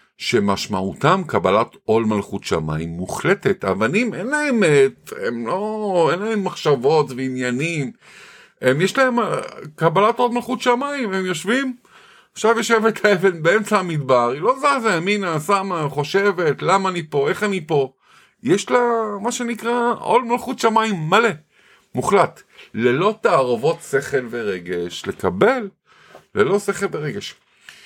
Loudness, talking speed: -19 LUFS, 125 wpm